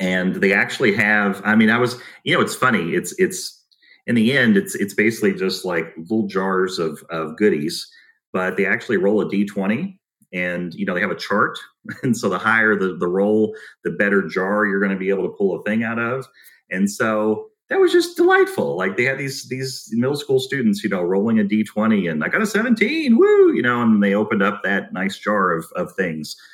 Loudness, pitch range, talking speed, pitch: -19 LUFS, 95-135 Hz, 220 wpm, 110 Hz